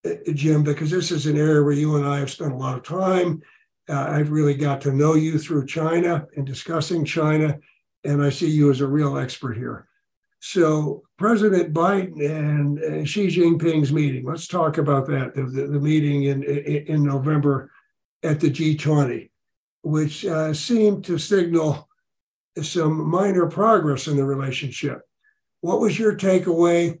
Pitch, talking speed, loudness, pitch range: 155 Hz, 165 wpm, -21 LUFS, 145-170 Hz